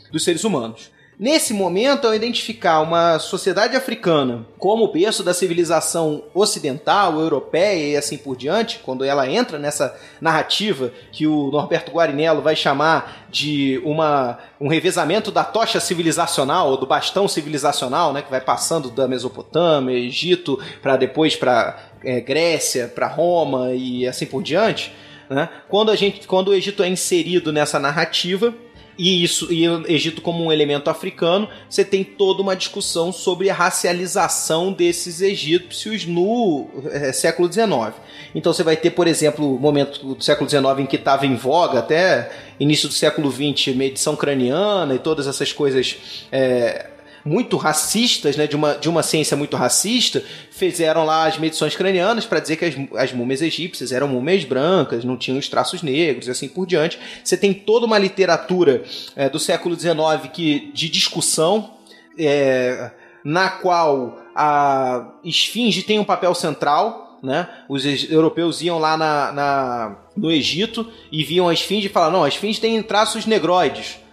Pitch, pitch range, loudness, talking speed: 160 Hz, 145-185 Hz, -19 LUFS, 160 wpm